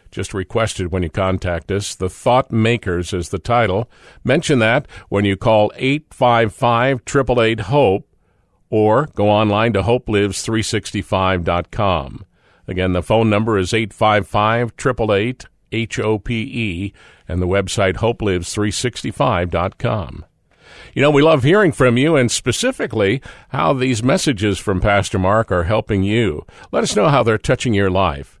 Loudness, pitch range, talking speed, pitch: -17 LUFS, 95-120 Hz, 135 wpm, 110 Hz